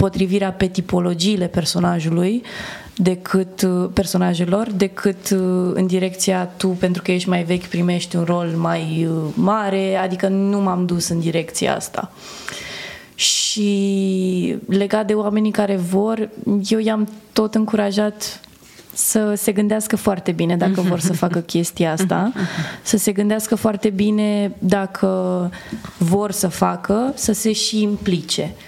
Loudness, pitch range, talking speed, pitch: -19 LUFS, 180-210 Hz, 130 wpm, 195 Hz